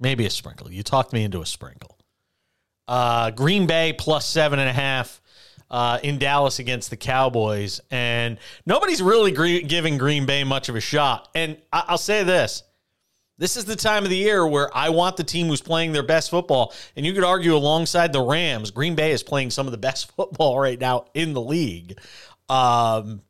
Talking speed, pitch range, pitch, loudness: 200 wpm, 120-165 Hz, 140 Hz, -21 LUFS